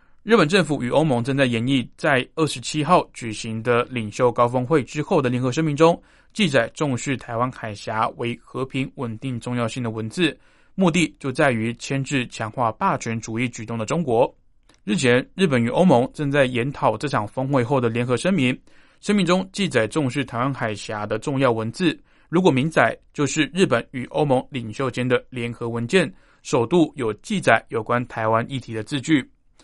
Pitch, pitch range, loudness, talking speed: 130 Hz, 115-150 Hz, -22 LUFS, 280 characters per minute